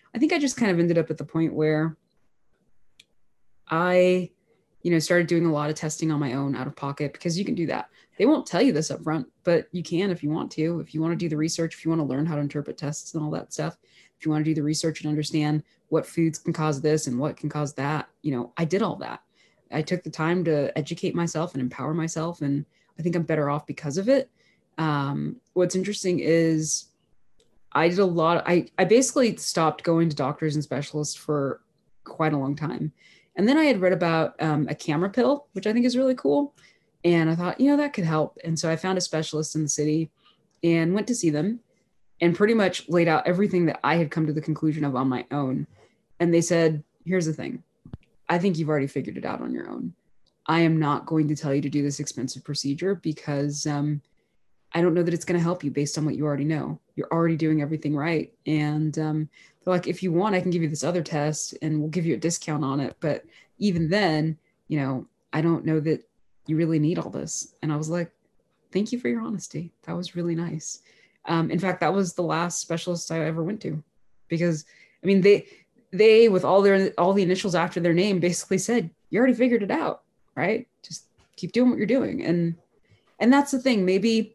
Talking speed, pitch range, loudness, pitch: 235 wpm, 150-180 Hz, -25 LUFS, 165 Hz